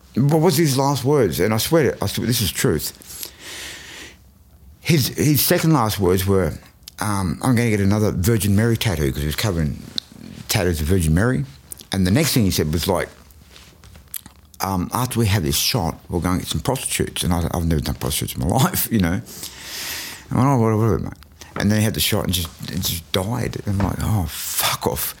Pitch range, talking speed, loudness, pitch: 85-115 Hz, 220 wpm, -20 LUFS, 100 Hz